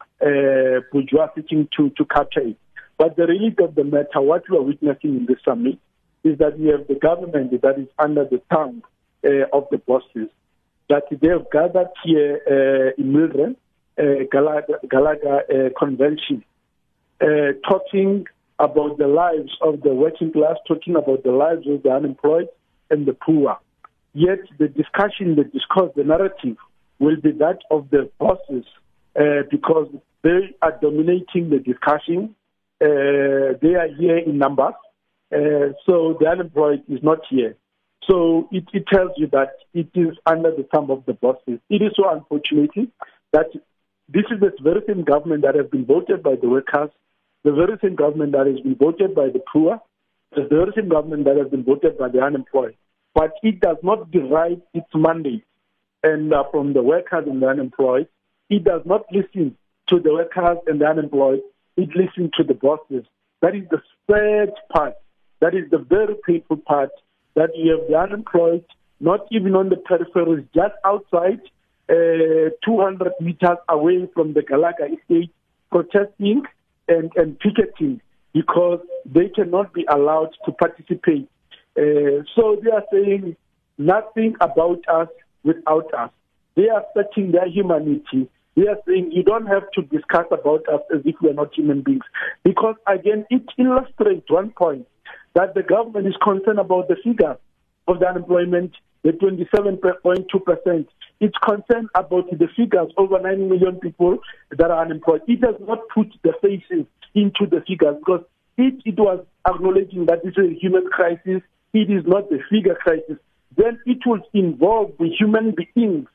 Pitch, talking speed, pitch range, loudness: 170 Hz, 170 wpm, 150-195 Hz, -19 LUFS